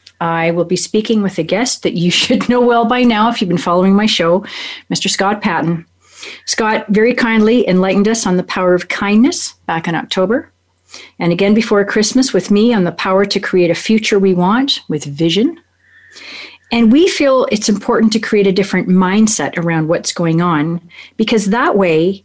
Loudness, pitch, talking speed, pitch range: -13 LUFS, 200 Hz, 190 wpm, 175-230 Hz